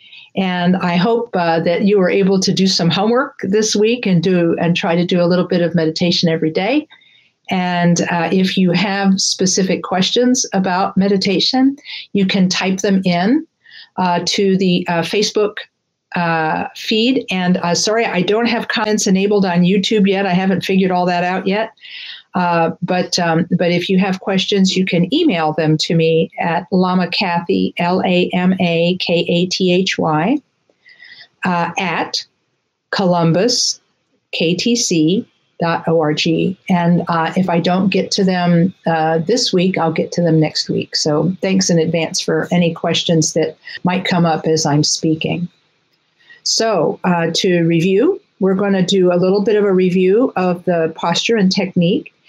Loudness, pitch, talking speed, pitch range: -15 LUFS, 180 Hz, 165 wpm, 170-200 Hz